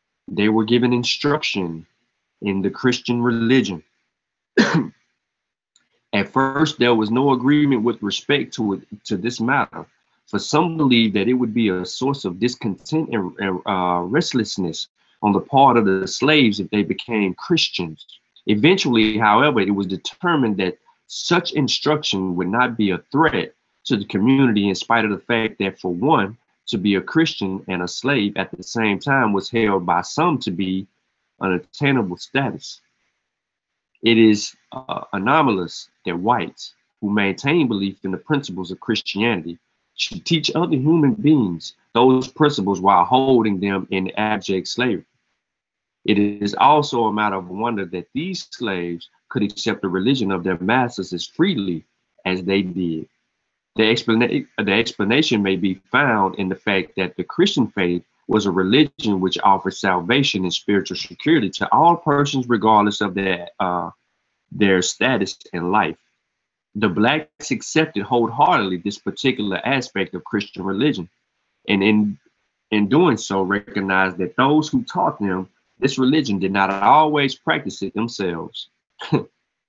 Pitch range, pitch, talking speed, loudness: 95-130 Hz, 105 Hz, 150 wpm, -19 LUFS